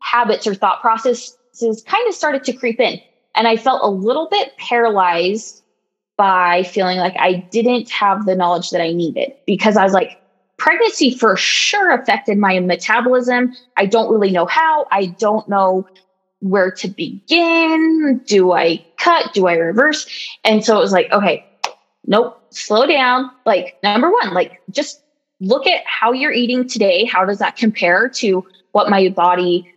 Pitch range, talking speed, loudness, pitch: 190-255 Hz, 165 wpm, -15 LUFS, 220 Hz